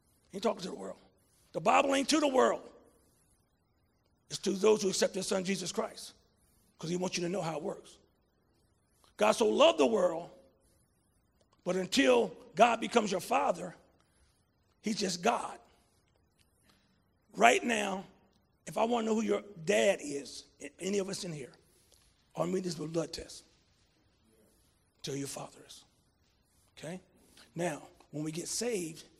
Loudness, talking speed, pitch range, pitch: -31 LUFS, 155 wpm, 125-200 Hz, 175 Hz